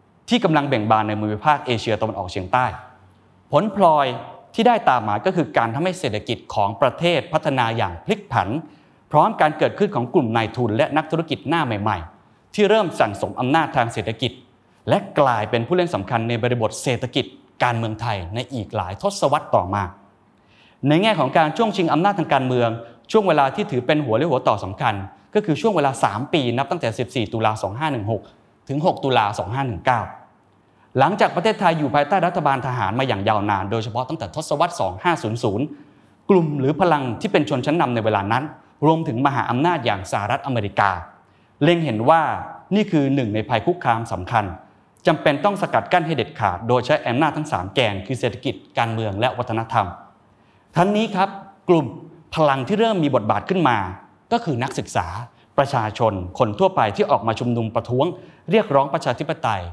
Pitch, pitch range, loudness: 130 Hz, 110-160 Hz, -20 LUFS